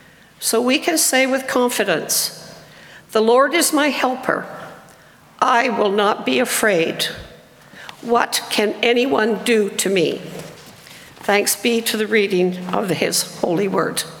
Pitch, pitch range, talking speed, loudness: 235 Hz, 215-260 Hz, 130 wpm, -18 LUFS